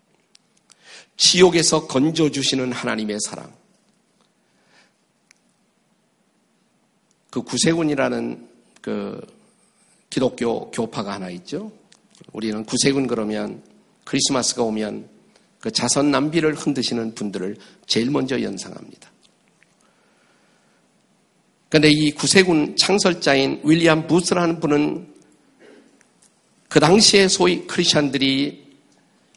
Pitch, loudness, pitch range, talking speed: 160 Hz, -19 LUFS, 135-200 Hz, 215 characters per minute